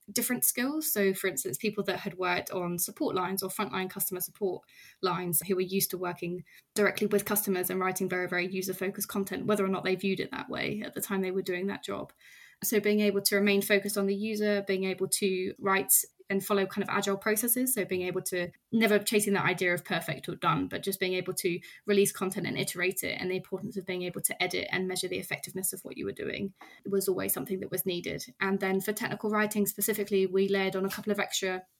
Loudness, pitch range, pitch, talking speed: -30 LUFS, 185-205 Hz, 195 Hz, 240 wpm